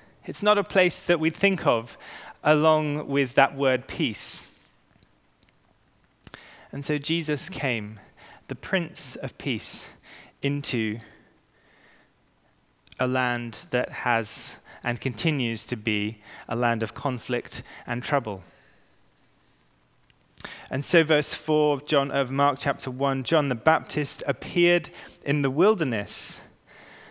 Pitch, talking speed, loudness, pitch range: 140 Hz, 115 wpm, -25 LUFS, 120-155 Hz